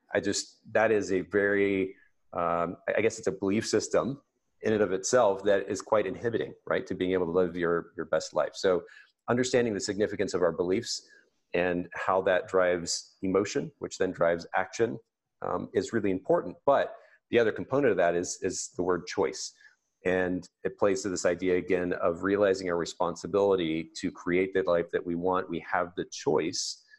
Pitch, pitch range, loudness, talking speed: 95 Hz, 85-100 Hz, -29 LUFS, 185 wpm